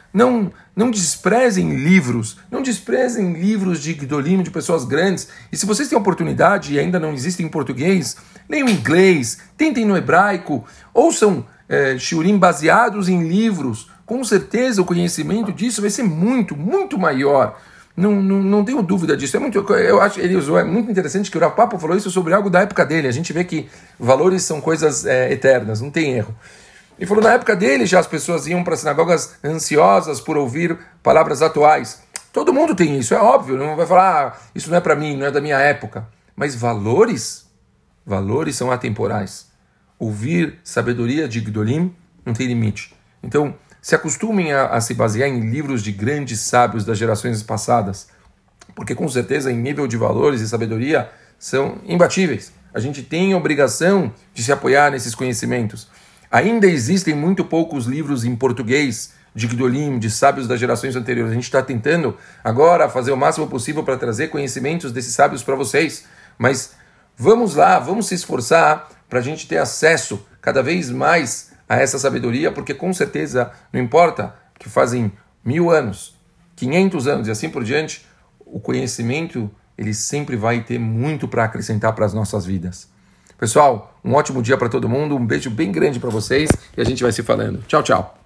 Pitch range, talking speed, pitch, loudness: 125-185 Hz, 180 wpm, 150 Hz, -18 LUFS